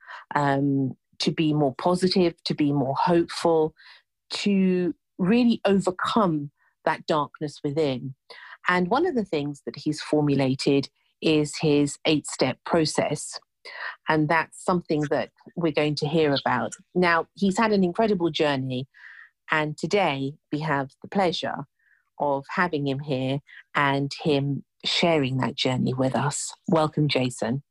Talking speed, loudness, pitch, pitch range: 135 wpm, -25 LUFS, 155 Hz, 140-175 Hz